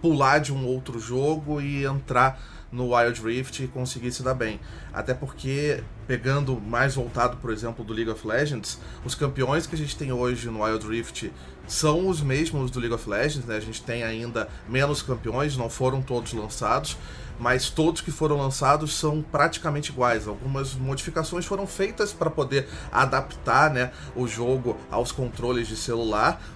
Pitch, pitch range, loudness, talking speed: 130 Hz, 115-145 Hz, -26 LUFS, 170 wpm